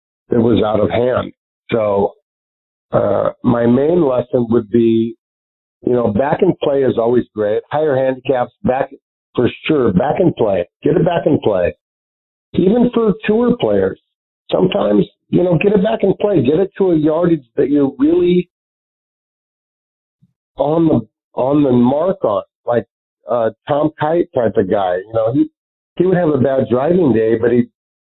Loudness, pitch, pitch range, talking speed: -15 LUFS, 135 Hz, 115-180 Hz, 165 wpm